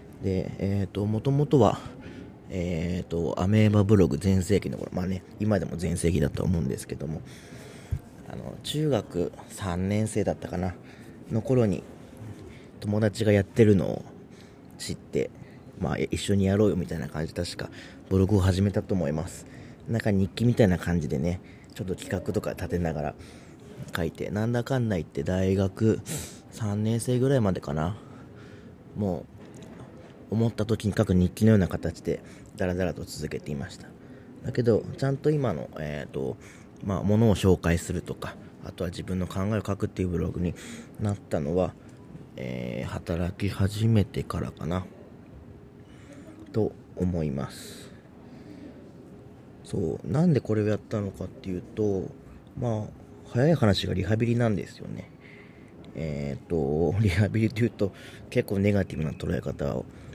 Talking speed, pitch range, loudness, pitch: 295 characters per minute, 90-110 Hz, -27 LUFS, 100 Hz